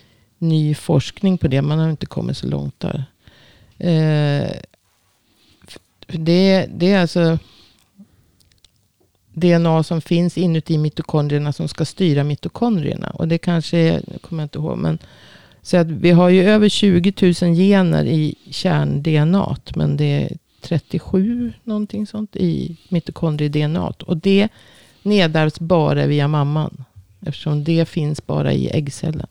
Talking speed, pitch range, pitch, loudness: 135 wpm, 150-180 Hz, 165 Hz, -18 LUFS